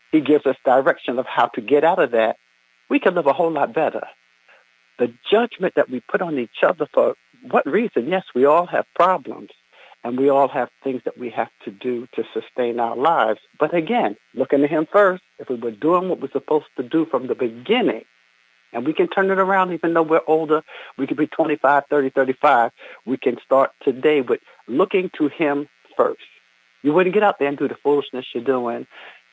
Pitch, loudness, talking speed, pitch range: 145 Hz, -20 LUFS, 210 wpm, 125-170 Hz